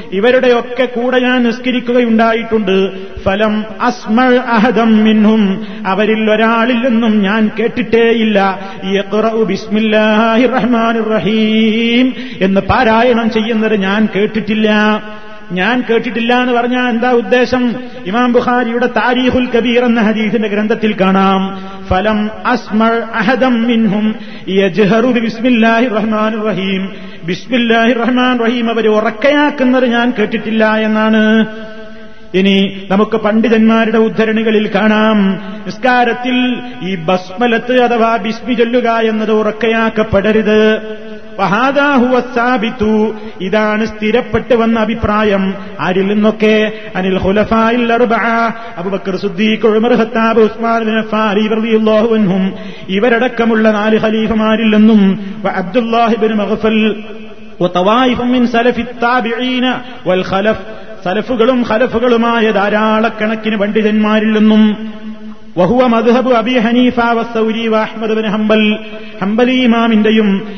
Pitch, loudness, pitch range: 220 Hz, -12 LUFS, 215-235 Hz